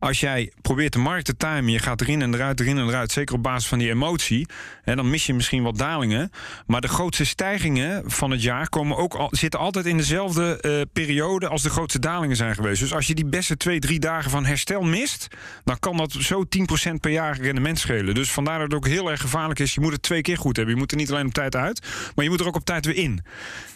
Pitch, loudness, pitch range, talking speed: 145 Hz, -23 LUFS, 130-165 Hz, 260 wpm